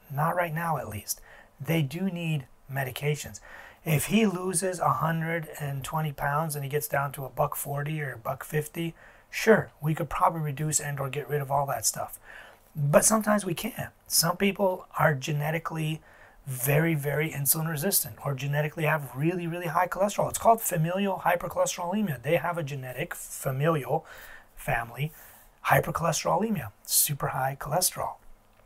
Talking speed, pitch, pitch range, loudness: 150 wpm, 155 Hz, 140-175 Hz, -28 LUFS